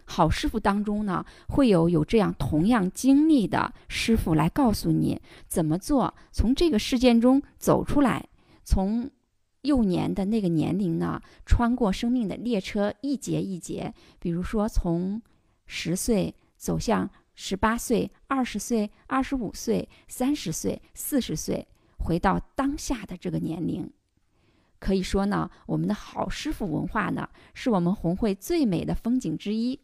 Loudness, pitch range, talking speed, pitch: -26 LUFS, 180-255 Hz, 225 characters per minute, 210 Hz